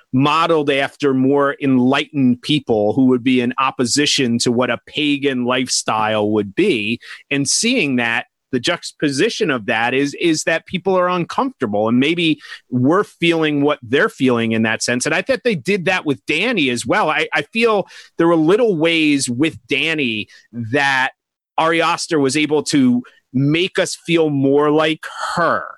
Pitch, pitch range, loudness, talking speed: 145 Hz, 125-165 Hz, -17 LUFS, 165 wpm